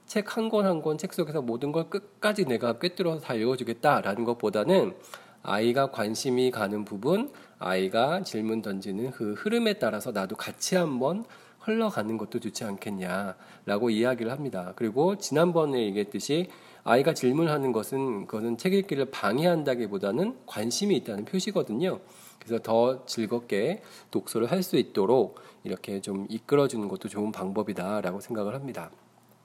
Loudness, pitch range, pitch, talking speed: -28 LUFS, 105-170 Hz, 120 Hz, 345 characters per minute